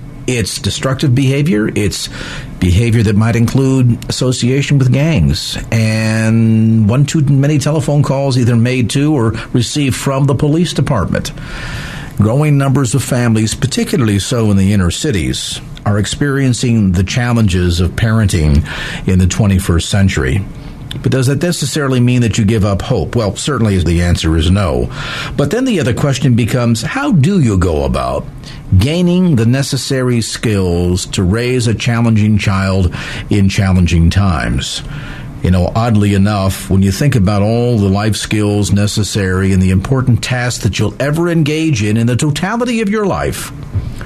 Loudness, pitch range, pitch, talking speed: -13 LUFS, 100-135 Hz, 115 Hz, 155 wpm